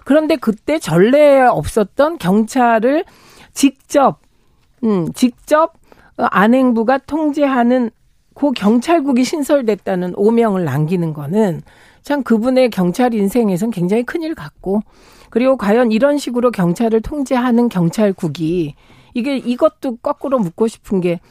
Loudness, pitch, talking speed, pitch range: -15 LUFS, 240 Hz, 275 characters per minute, 205-275 Hz